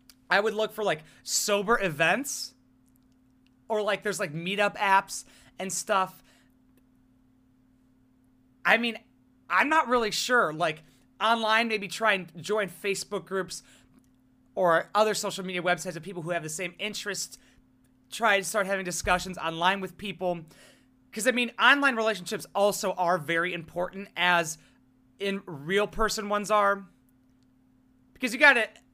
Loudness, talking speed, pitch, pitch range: -27 LUFS, 140 wpm, 180 Hz, 130-205 Hz